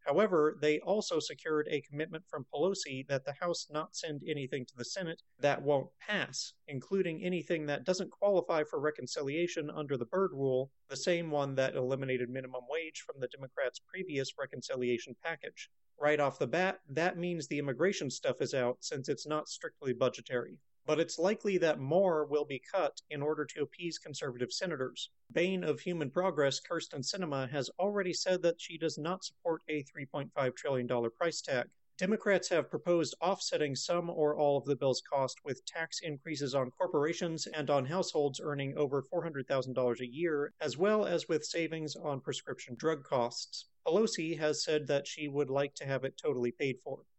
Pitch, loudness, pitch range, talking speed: 150 Hz, -35 LUFS, 135-170 Hz, 185 wpm